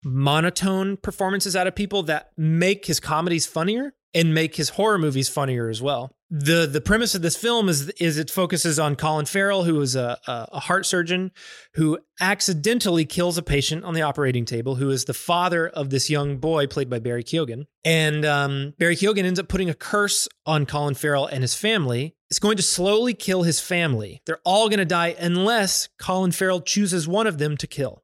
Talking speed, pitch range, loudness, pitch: 200 wpm, 145-190 Hz, -22 LUFS, 165 Hz